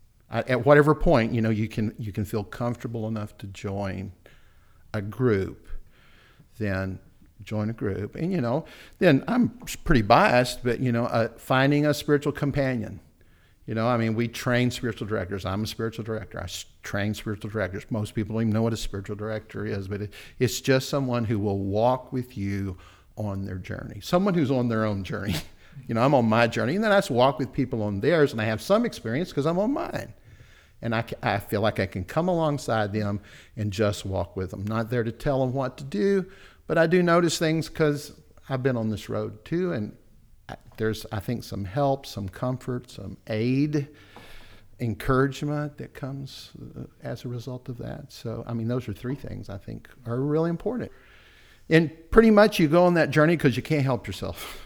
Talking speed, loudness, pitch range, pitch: 200 wpm, -26 LUFS, 105-140 Hz, 115 Hz